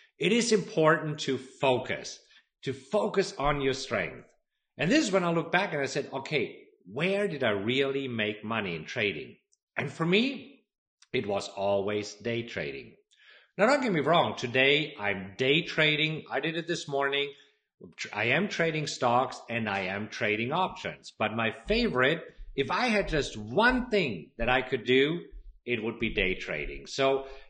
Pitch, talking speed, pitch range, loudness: 140 Hz, 170 wpm, 120-185 Hz, -28 LUFS